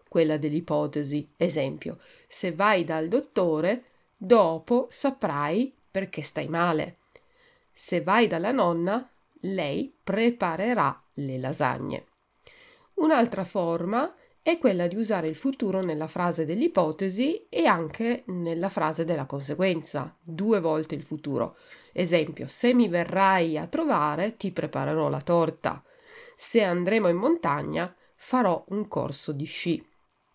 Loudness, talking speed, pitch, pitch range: -26 LUFS, 120 wpm, 185 Hz, 160-240 Hz